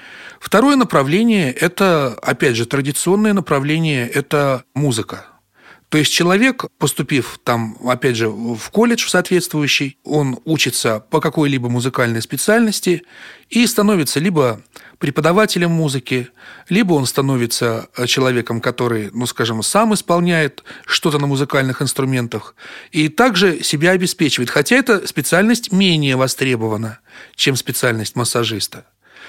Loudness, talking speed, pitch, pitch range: -16 LUFS, 115 wpm, 145 Hz, 125-180 Hz